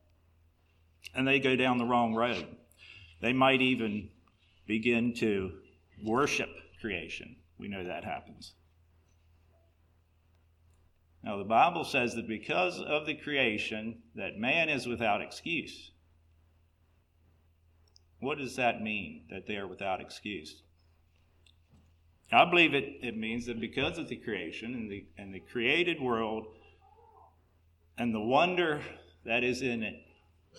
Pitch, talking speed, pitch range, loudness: 95 Hz, 125 wpm, 85-120 Hz, -31 LUFS